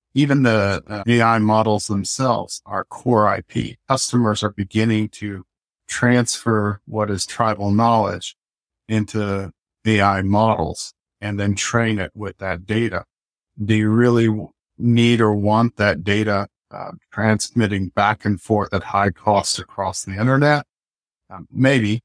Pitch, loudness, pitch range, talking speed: 105 Hz, -19 LUFS, 100-115 Hz, 135 wpm